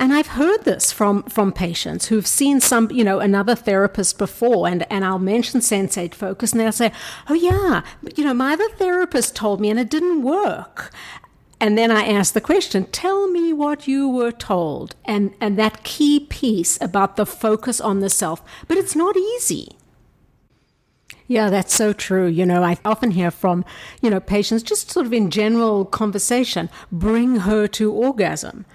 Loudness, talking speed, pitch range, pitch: -19 LUFS, 180 wpm, 200-265 Hz, 220 Hz